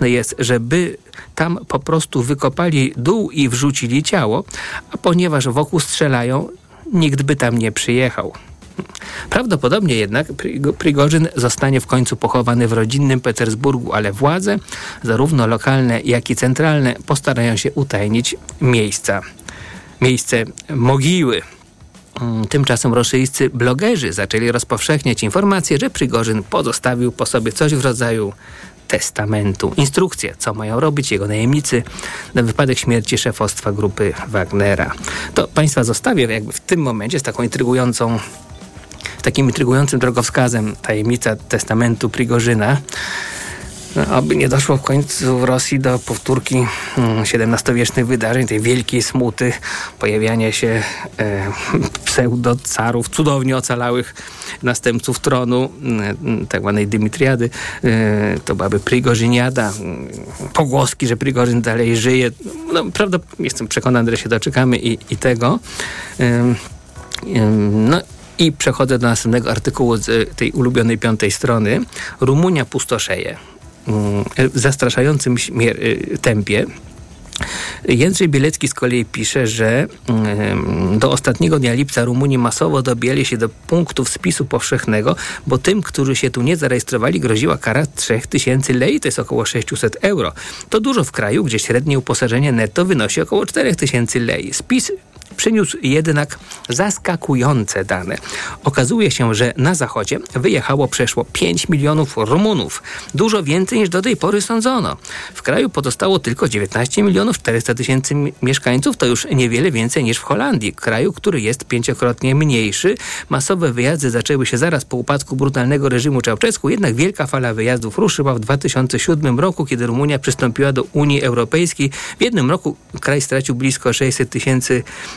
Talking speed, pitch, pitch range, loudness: 130 wpm, 125 Hz, 115-140 Hz, -16 LUFS